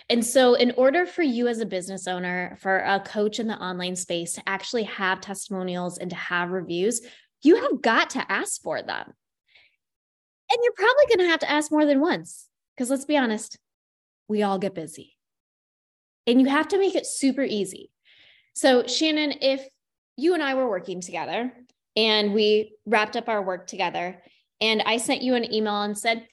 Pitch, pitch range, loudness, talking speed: 220 Hz, 190-270 Hz, -24 LUFS, 190 wpm